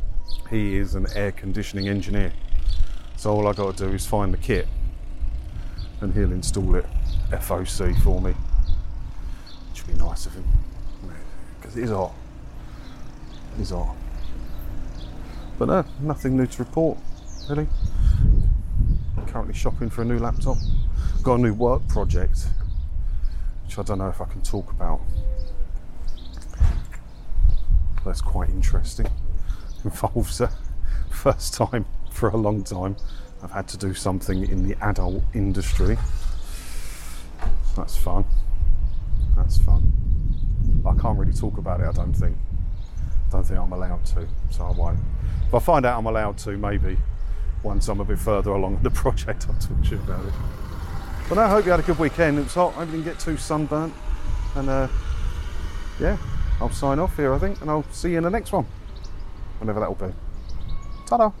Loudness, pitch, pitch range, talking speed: -25 LUFS, 95 Hz, 80-105 Hz, 160 wpm